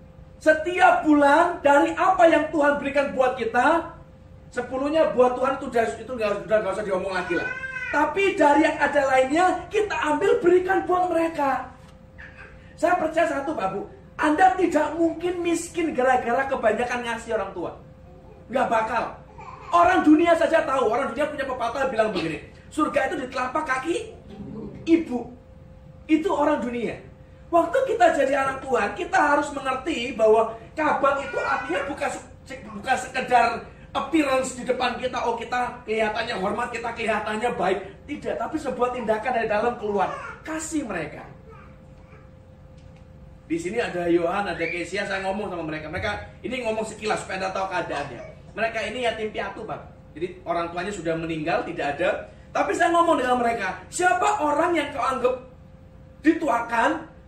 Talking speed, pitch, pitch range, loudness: 150 wpm, 265 Hz, 230-320 Hz, -23 LUFS